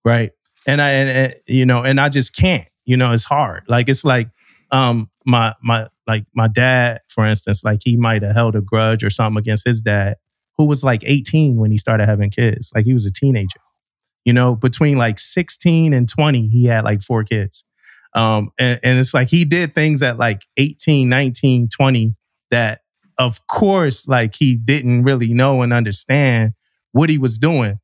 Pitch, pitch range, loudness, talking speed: 120 Hz, 110-135 Hz, -15 LUFS, 195 wpm